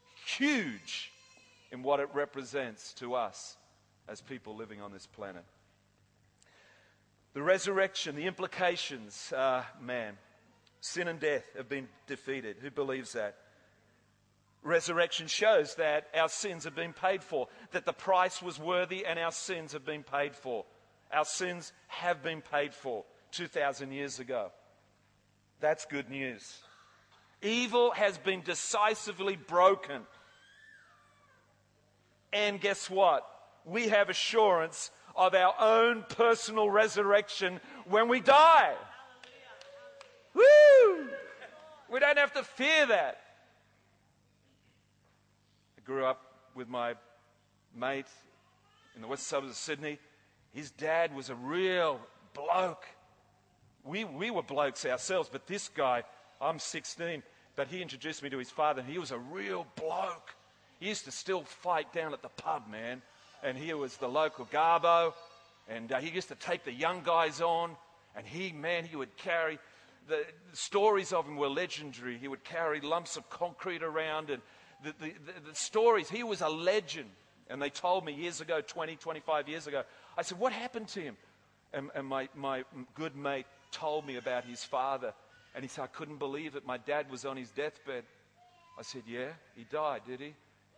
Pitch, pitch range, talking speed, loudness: 155 Hz, 125-185 Hz, 155 wpm, -32 LUFS